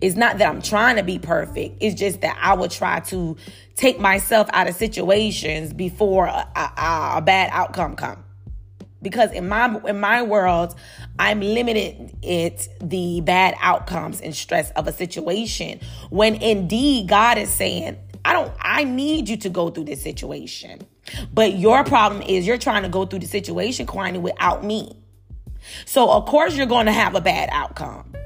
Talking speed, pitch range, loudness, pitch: 175 wpm, 175-220 Hz, -20 LUFS, 195 Hz